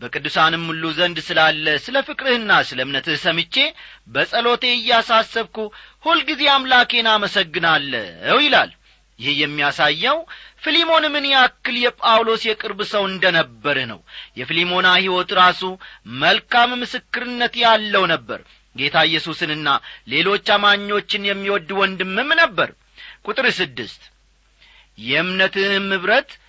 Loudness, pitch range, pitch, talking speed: -17 LUFS, 160-240 Hz, 195 Hz, 100 wpm